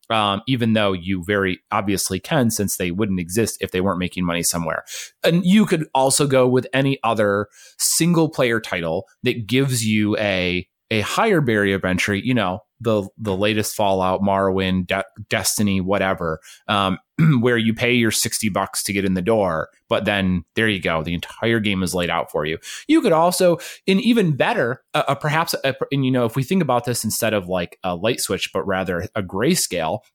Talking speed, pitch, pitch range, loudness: 200 wpm, 110 Hz, 95-130 Hz, -20 LUFS